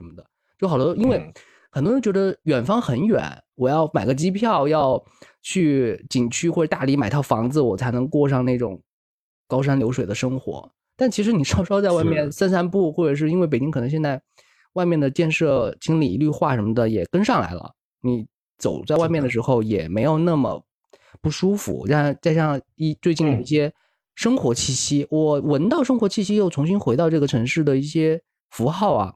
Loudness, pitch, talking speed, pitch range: -21 LUFS, 150 Hz, 290 characters per minute, 130-170 Hz